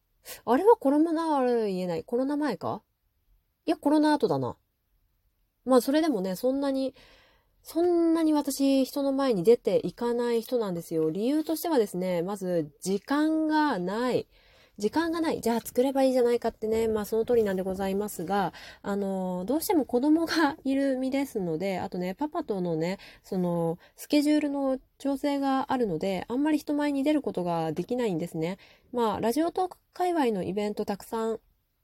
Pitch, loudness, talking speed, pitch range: 245 Hz, -27 LUFS, 355 characters per minute, 195-295 Hz